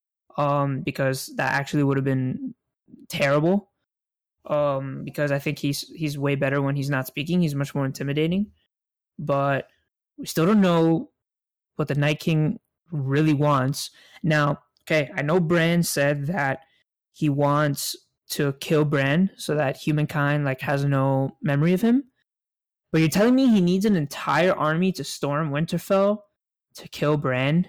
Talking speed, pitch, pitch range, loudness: 155 wpm, 150 Hz, 140-170 Hz, -23 LUFS